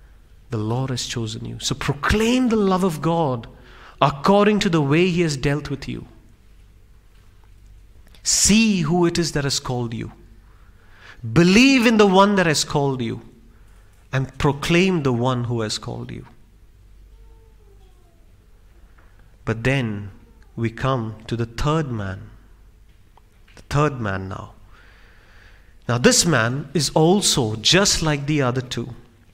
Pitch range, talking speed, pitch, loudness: 100-150 Hz, 135 wpm, 115 Hz, -19 LUFS